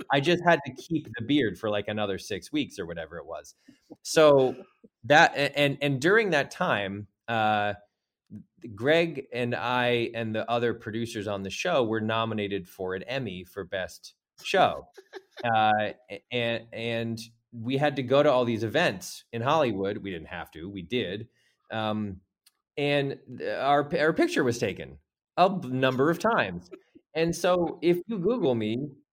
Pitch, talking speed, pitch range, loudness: 120 Hz, 160 wpm, 110-150 Hz, -27 LUFS